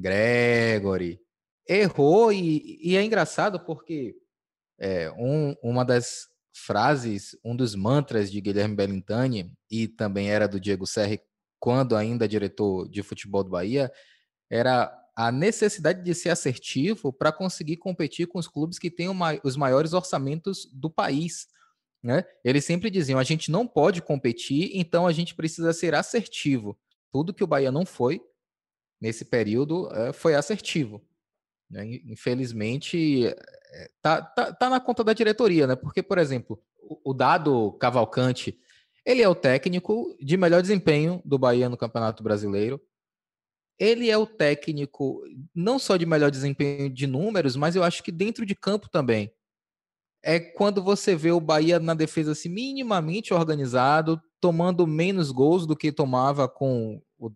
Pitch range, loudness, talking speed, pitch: 120-180 Hz, -25 LUFS, 150 wpm, 150 Hz